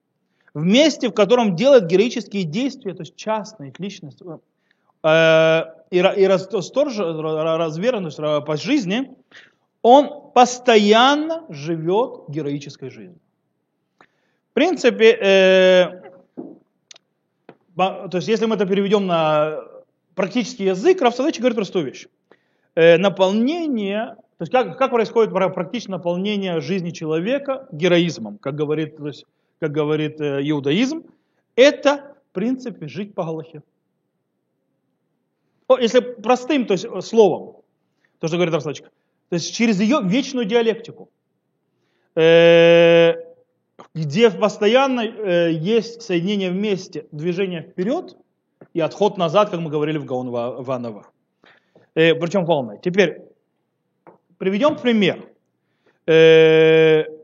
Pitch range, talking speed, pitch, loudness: 160-235 Hz, 105 wpm, 190 Hz, -18 LUFS